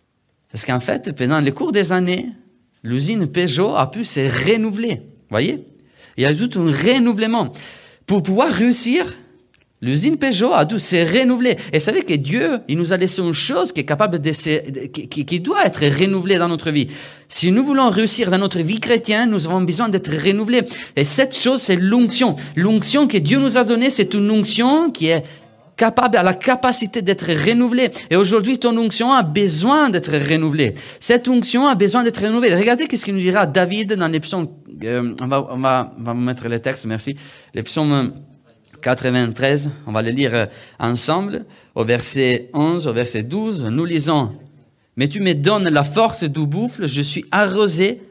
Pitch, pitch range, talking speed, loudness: 180 Hz, 145-225 Hz, 185 wpm, -17 LUFS